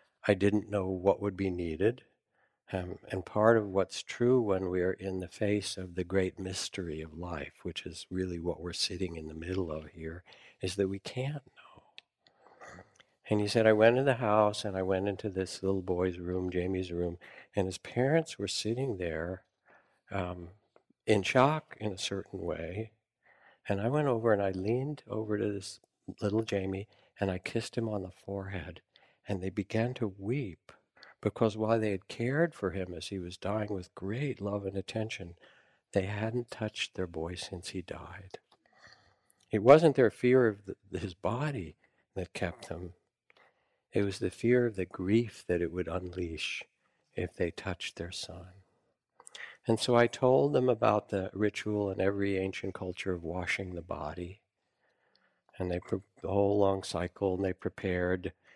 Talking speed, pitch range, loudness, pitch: 175 wpm, 90-110 Hz, -32 LUFS, 95 Hz